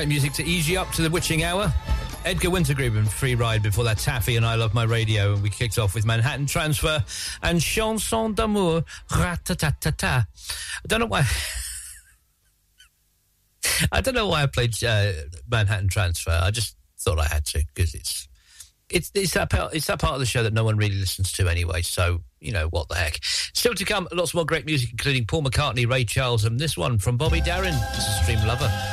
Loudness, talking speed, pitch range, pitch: -23 LUFS, 205 wpm, 95-155 Hz, 115 Hz